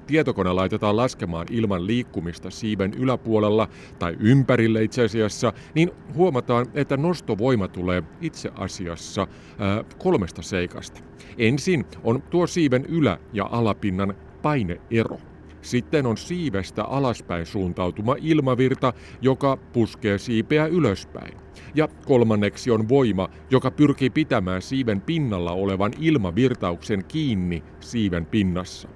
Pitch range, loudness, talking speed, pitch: 95-130 Hz, -23 LUFS, 110 wpm, 110 Hz